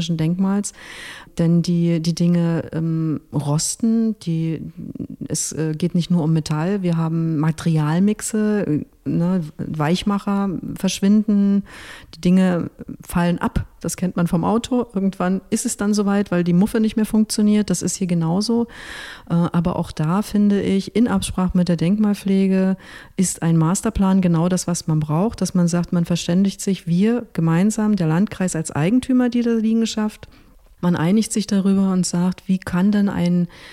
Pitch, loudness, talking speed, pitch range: 185 Hz, -20 LUFS, 155 wpm, 170-205 Hz